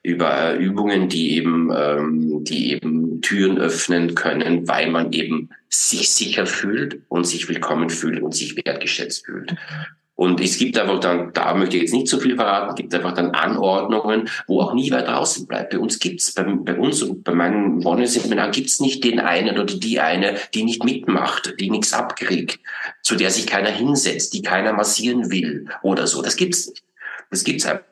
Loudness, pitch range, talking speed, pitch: -19 LUFS, 85-120 Hz, 200 wpm, 95 Hz